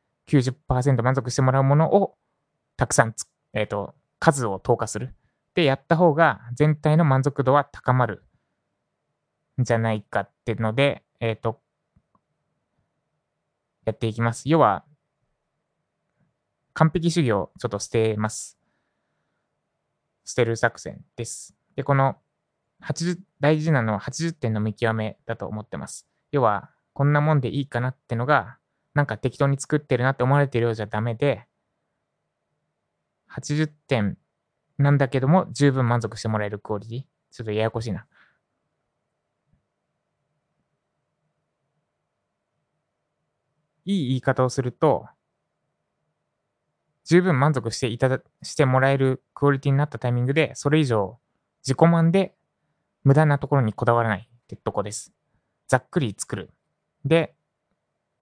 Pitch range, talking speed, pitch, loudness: 115-150 Hz, 260 characters per minute, 135 Hz, -23 LUFS